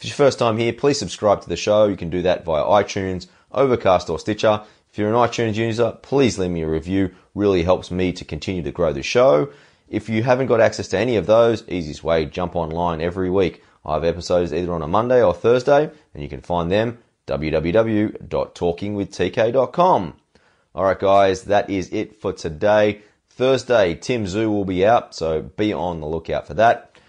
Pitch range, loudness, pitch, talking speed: 85-110 Hz, -20 LUFS, 100 Hz, 195 wpm